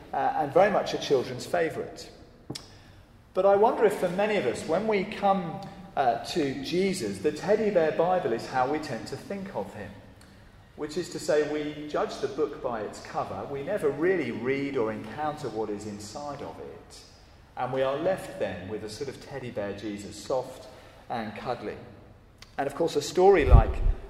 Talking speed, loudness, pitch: 190 wpm, -28 LUFS, 140 Hz